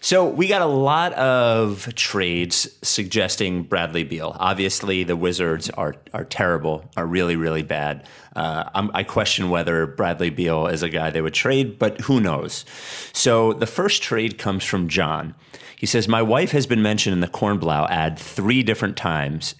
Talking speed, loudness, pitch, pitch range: 175 wpm, -21 LUFS, 95 Hz, 85-110 Hz